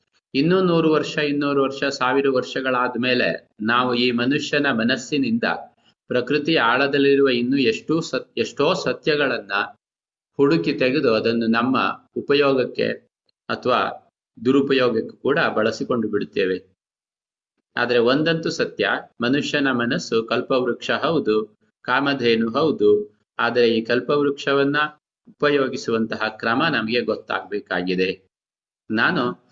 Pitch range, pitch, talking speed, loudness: 115-140 Hz, 130 Hz, 95 wpm, -21 LUFS